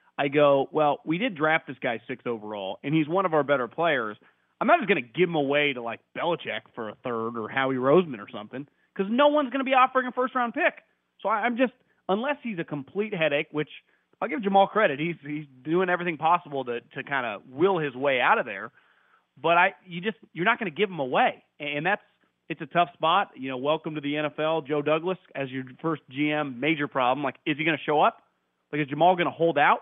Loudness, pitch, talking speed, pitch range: -26 LUFS, 160 Hz, 235 wpm, 145-190 Hz